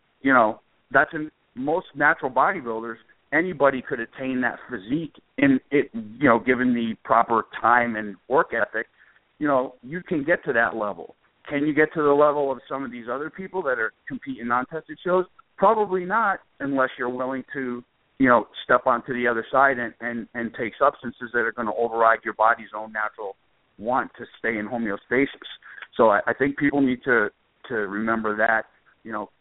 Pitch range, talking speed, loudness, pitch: 115-145 Hz, 190 wpm, -23 LUFS, 125 Hz